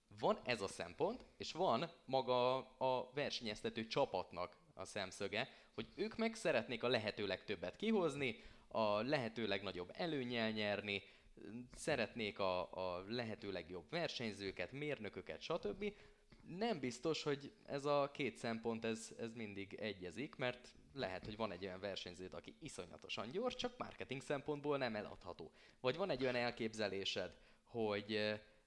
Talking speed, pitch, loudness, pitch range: 135 wpm, 115 Hz, -43 LUFS, 100-135 Hz